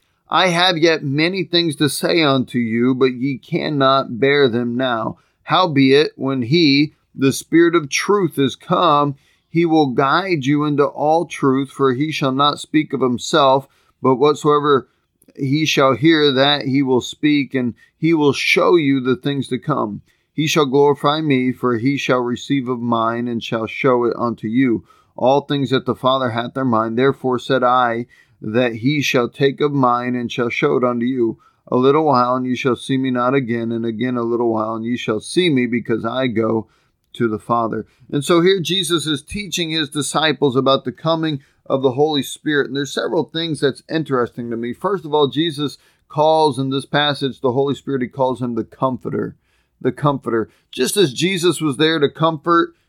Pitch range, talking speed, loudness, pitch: 125-150 Hz, 190 wpm, -17 LUFS, 135 Hz